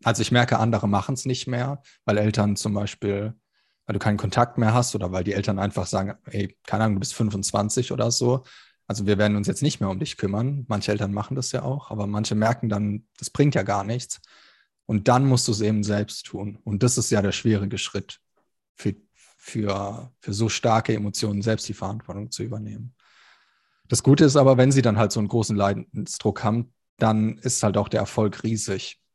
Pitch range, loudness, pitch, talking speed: 105-120 Hz, -24 LUFS, 110 Hz, 210 wpm